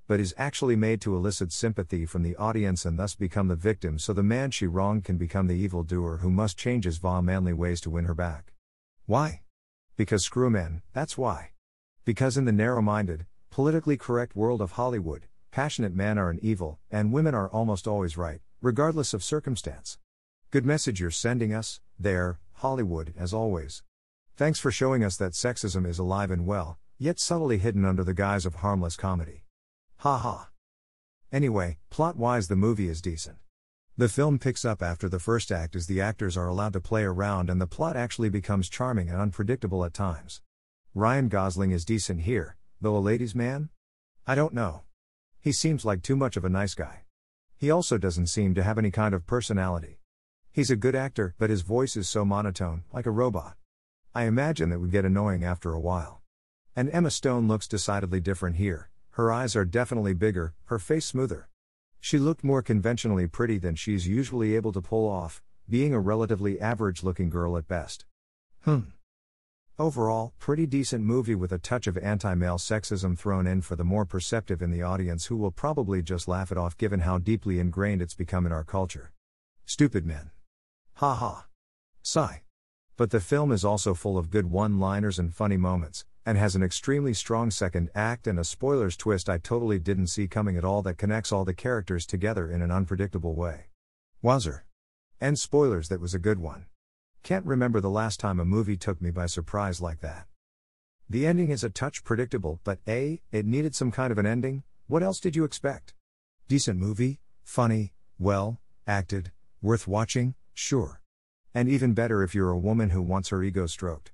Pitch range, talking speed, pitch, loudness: 90-115 Hz, 190 wpm, 100 Hz, -28 LUFS